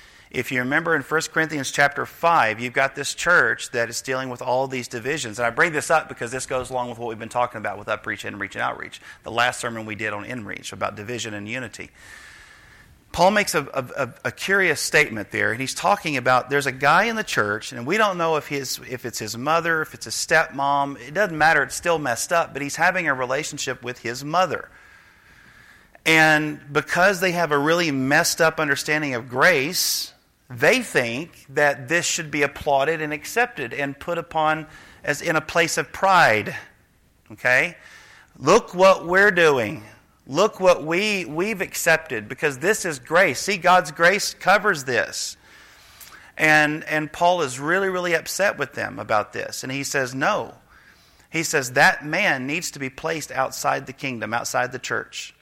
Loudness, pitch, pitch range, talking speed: -21 LUFS, 145 Hz, 125-165 Hz, 190 wpm